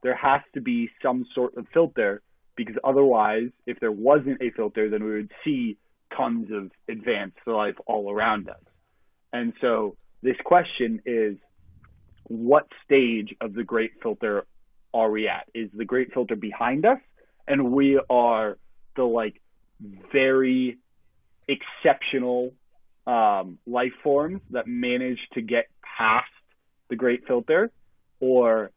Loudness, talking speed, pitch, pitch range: -24 LUFS, 135 wpm, 120 Hz, 110-130 Hz